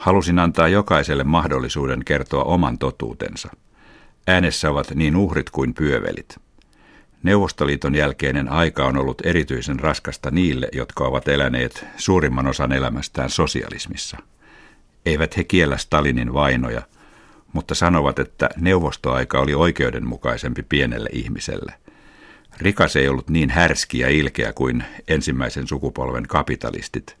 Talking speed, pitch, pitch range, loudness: 115 wpm, 70 Hz, 65-85 Hz, -20 LUFS